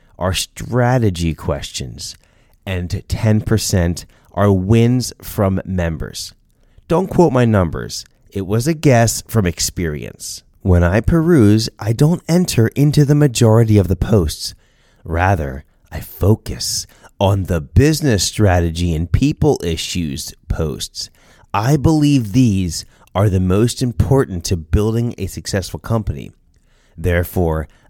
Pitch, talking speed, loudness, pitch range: 100 Hz, 120 wpm, -16 LUFS, 90-120 Hz